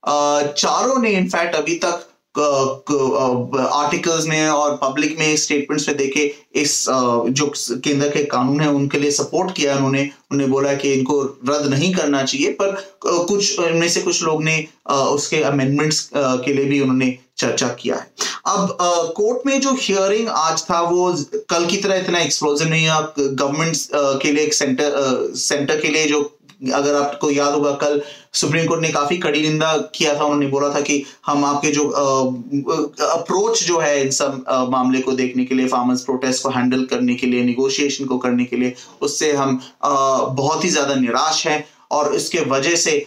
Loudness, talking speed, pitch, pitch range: -18 LUFS, 175 wpm, 145 Hz, 135-160 Hz